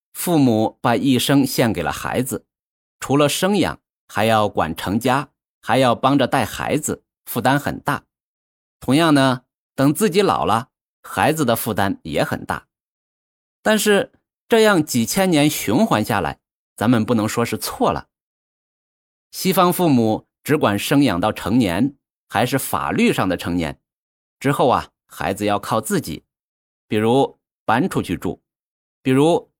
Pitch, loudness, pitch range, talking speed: 130 Hz, -19 LUFS, 105-165 Hz, 205 characters per minute